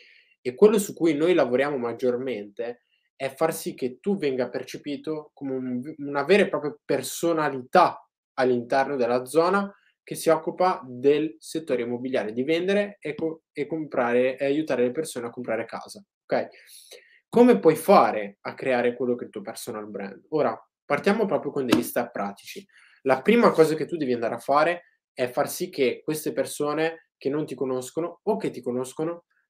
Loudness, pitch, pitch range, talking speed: -25 LUFS, 150 Hz, 125-170 Hz, 175 wpm